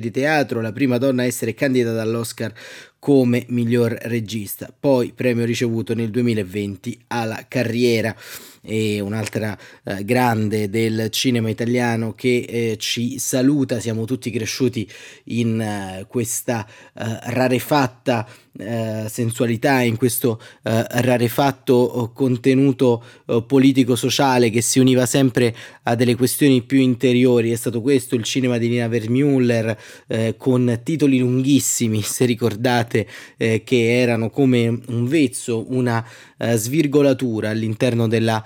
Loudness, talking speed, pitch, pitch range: -19 LUFS, 110 wpm, 120 Hz, 115-130 Hz